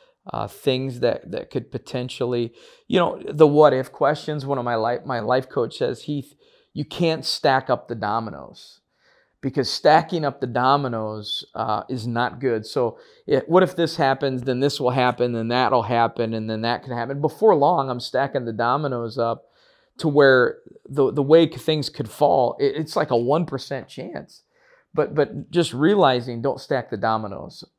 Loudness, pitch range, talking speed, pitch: -22 LUFS, 120-150 Hz, 180 wpm, 130 Hz